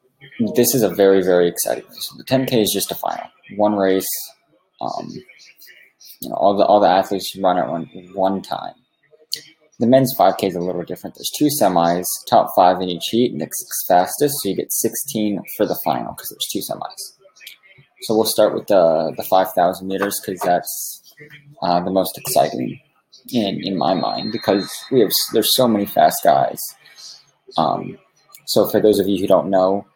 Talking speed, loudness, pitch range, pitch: 185 wpm, -18 LUFS, 95-130 Hz, 100 Hz